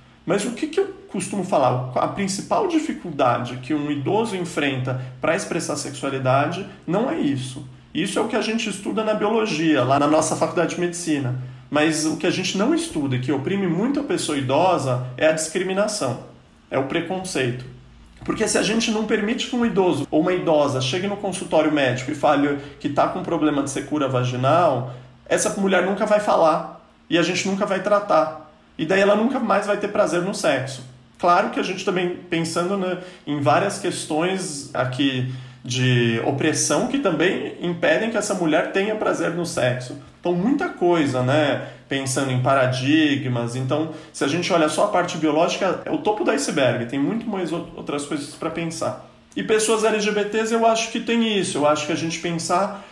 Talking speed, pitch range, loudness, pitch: 190 wpm, 140-200 Hz, -21 LUFS, 165 Hz